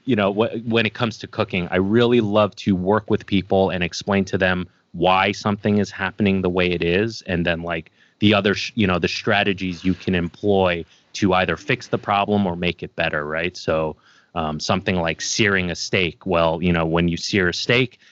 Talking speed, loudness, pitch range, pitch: 215 wpm, -20 LUFS, 85-105 Hz, 95 Hz